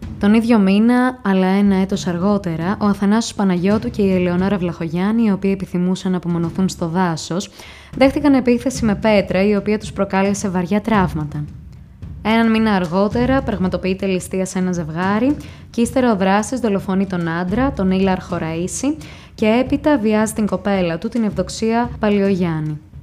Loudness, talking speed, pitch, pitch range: -18 LUFS, 145 wpm, 195 Hz, 185-220 Hz